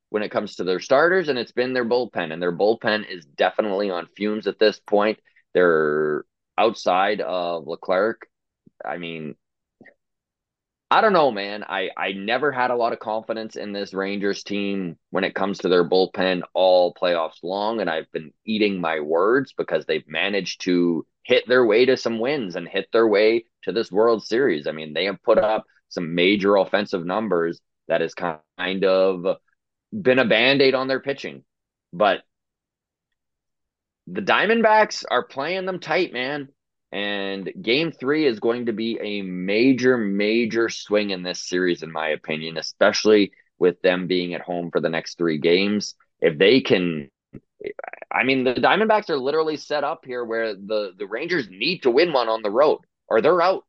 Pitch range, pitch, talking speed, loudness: 90-125 Hz, 100 Hz, 175 wpm, -21 LUFS